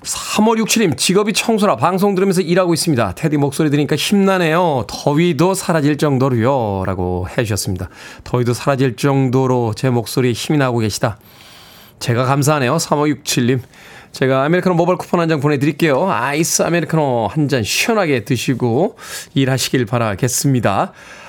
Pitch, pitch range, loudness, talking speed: 145 Hz, 125-170 Hz, -16 LUFS, 365 characters per minute